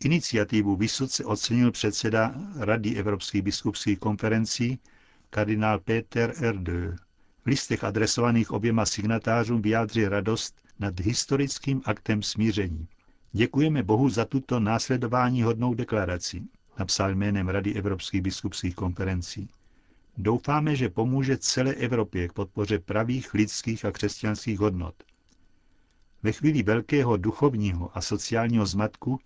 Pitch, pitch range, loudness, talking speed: 110 Hz, 100-120 Hz, -26 LUFS, 110 wpm